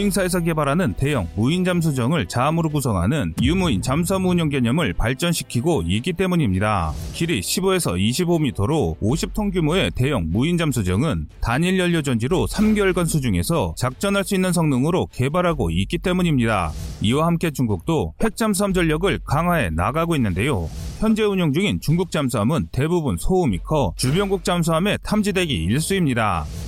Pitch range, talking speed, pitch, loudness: 120-185 Hz, 360 characters per minute, 160 Hz, -21 LUFS